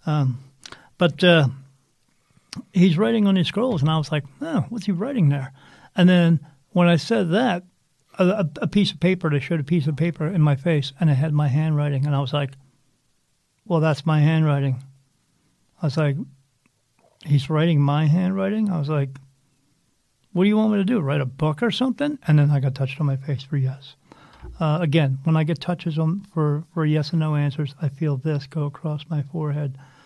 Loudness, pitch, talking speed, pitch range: -22 LUFS, 155 Hz, 205 wpm, 140-175 Hz